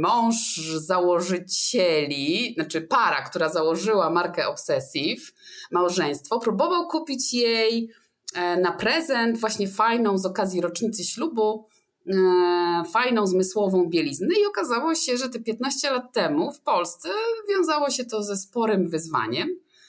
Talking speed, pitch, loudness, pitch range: 120 wpm, 220 Hz, -22 LUFS, 180-270 Hz